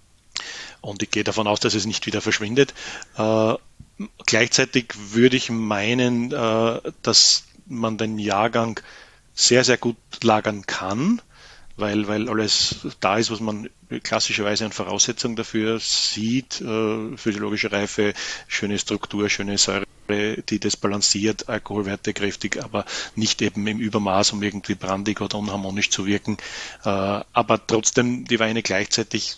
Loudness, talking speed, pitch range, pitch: -21 LUFS, 135 wpm, 105-115 Hz, 110 Hz